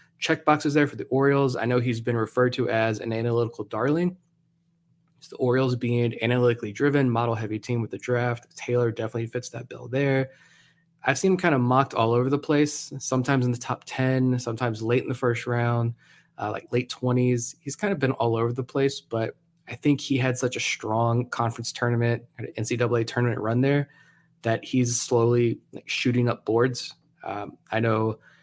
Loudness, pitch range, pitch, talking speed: -25 LUFS, 120-140 Hz, 125 Hz, 195 wpm